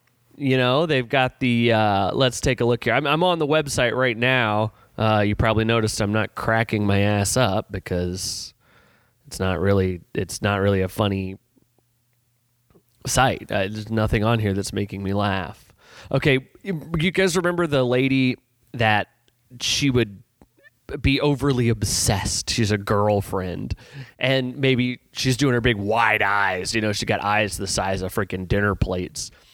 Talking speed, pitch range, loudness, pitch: 165 wpm, 100-130 Hz, -21 LUFS, 115 Hz